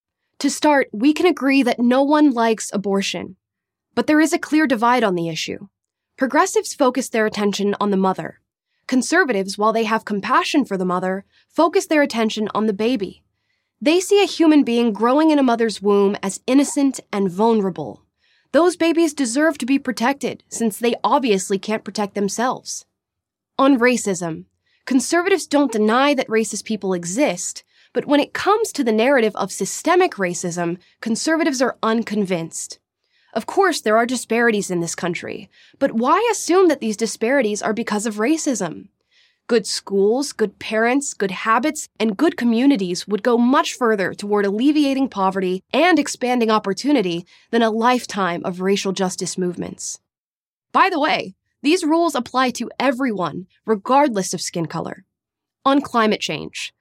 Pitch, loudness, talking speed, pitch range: 230 Hz, -19 LUFS, 155 wpm, 200-280 Hz